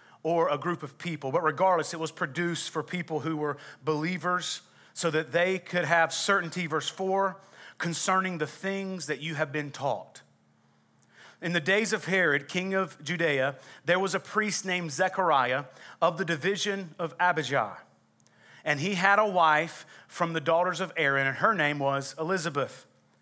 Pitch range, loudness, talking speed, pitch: 150-185 Hz, -28 LUFS, 170 wpm, 170 Hz